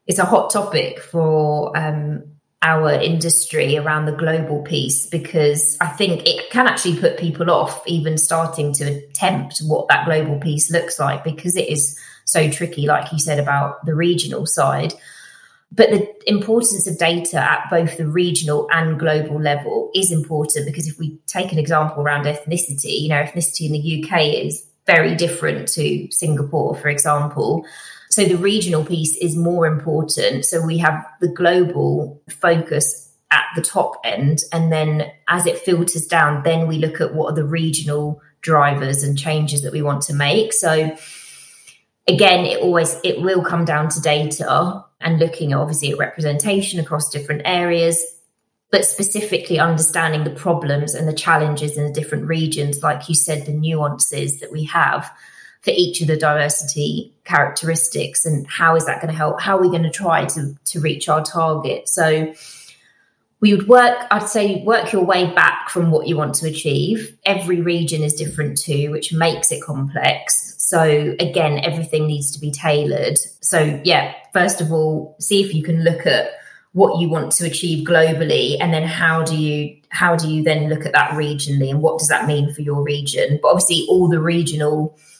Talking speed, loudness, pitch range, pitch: 180 wpm, -17 LUFS, 150-170 Hz, 160 Hz